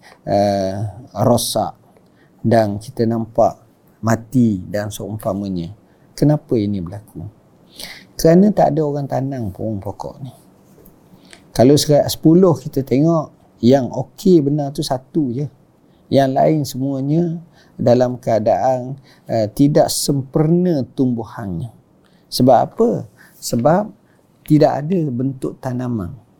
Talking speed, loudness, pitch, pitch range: 105 wpm, -17 LUFS, 130 Hz, 110-150 Hz